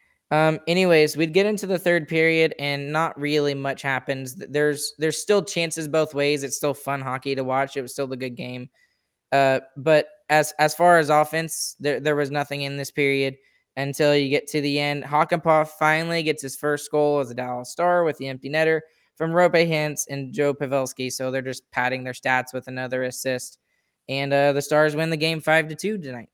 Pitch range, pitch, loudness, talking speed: 135-160 Hz, 145 Hz, -22 LUFS, 205 wpm